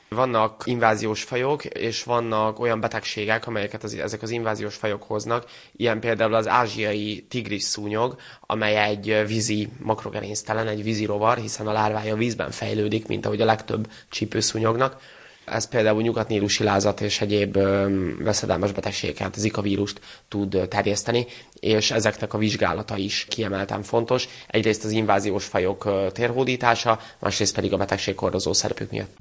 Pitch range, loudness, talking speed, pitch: 105-115 Hz, -24 LUFS, 140 wpm, 110 Hz